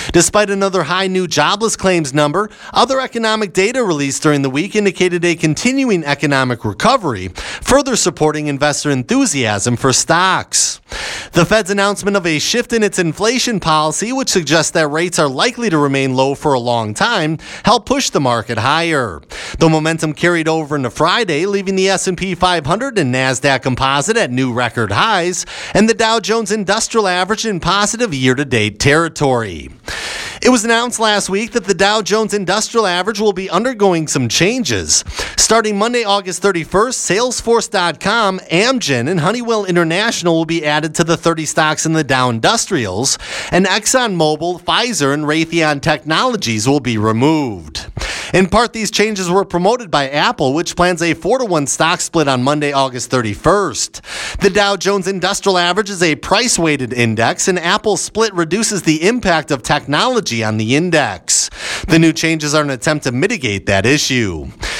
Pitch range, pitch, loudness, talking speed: 145-200 Hz, 170 Hz, -14 LUFS, 165 wpm